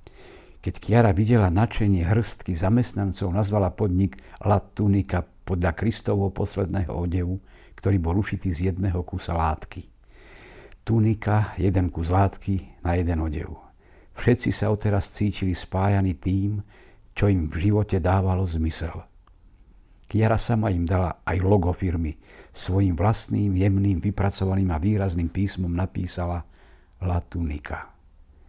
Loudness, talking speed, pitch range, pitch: -24 LUFS, 120 wpm, 90-100 Hz, 95 Hz